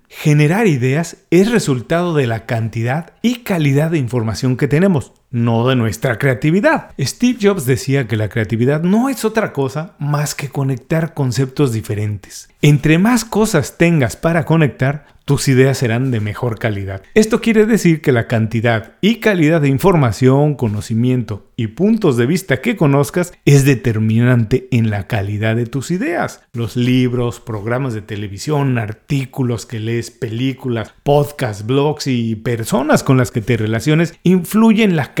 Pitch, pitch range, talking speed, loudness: 135 Hz, 120-165 Hz, 155 wpm, -16 LUFS